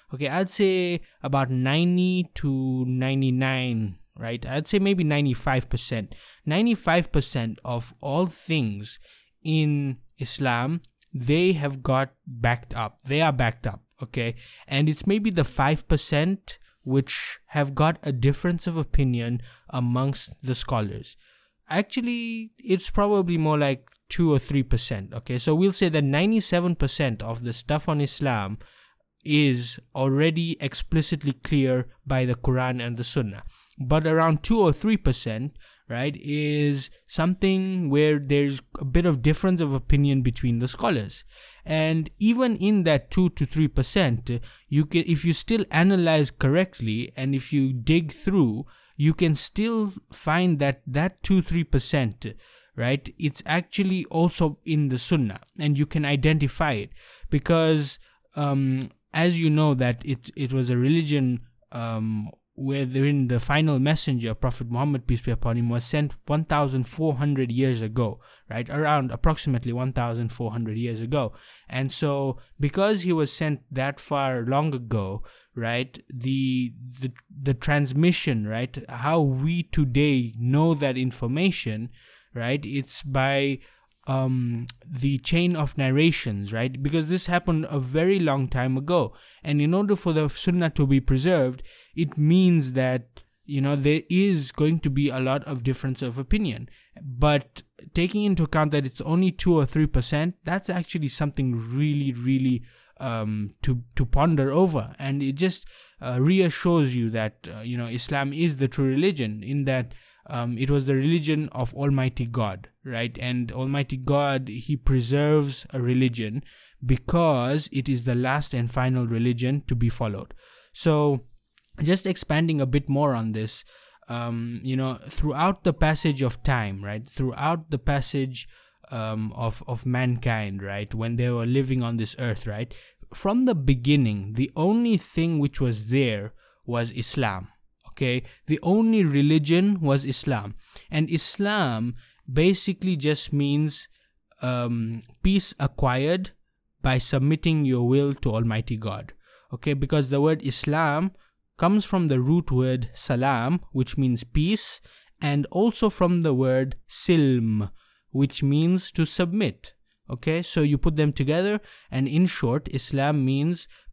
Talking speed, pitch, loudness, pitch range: 145 wpm, 140 Hz, -24 LUFS, 125-160 Hz